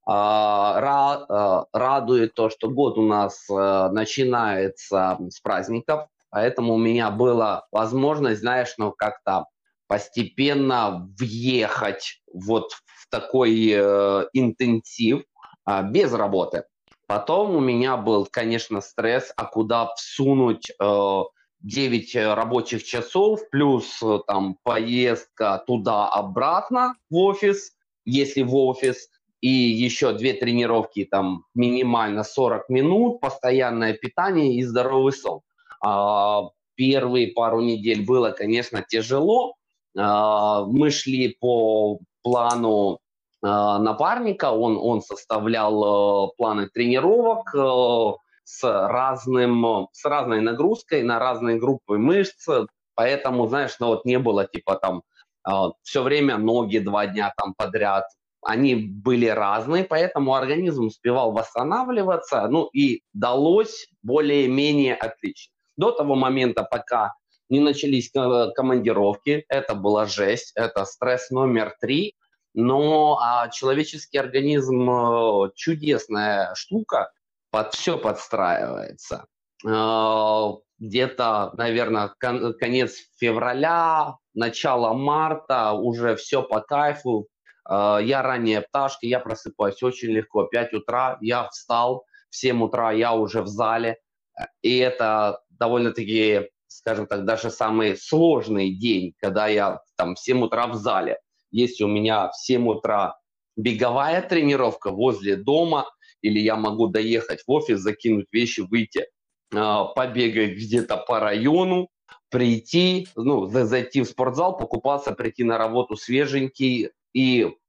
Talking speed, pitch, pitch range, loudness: 115 wpm, 120 Hz, 110-135 Hz, -22 LUFS